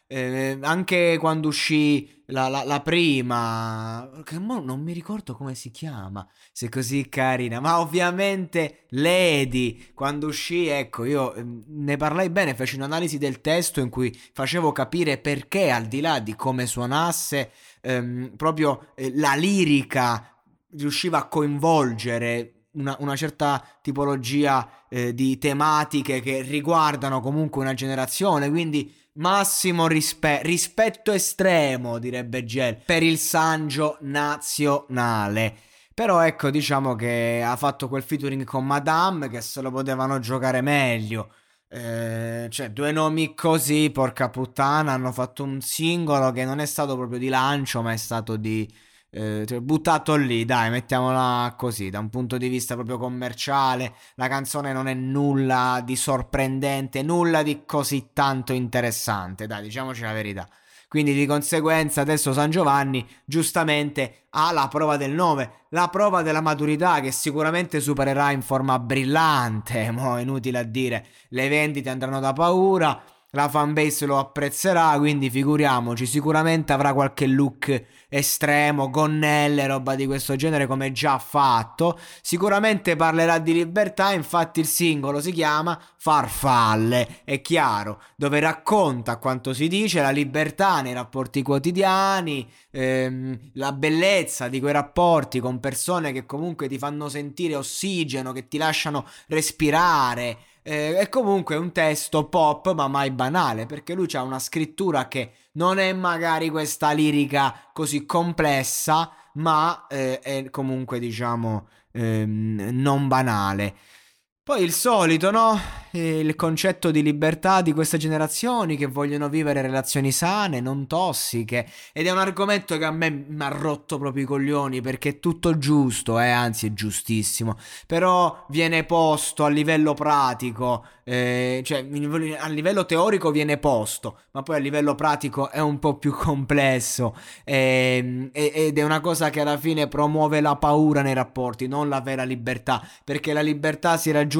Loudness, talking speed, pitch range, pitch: -23 LUFS, 145 wpm, 130-155 Hz, 140 Hz